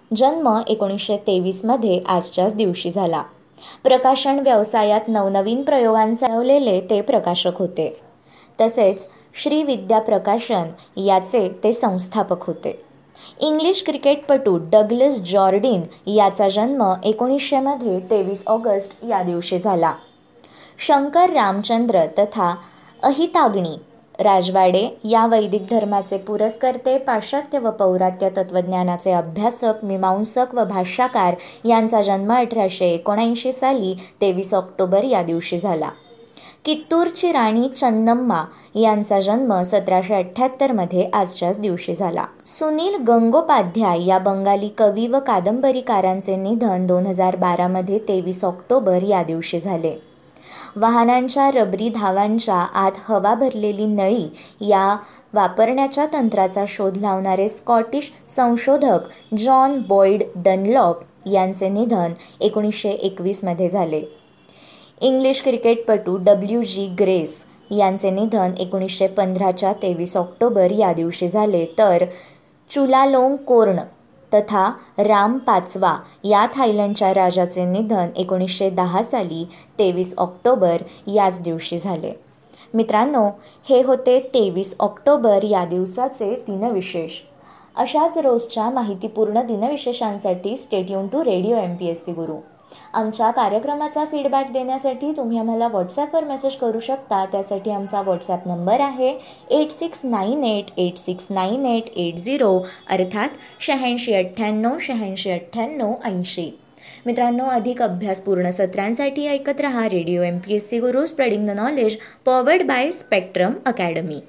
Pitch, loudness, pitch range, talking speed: 210 Hz, -19 LUFS, 185-245 Hz, 110 wpm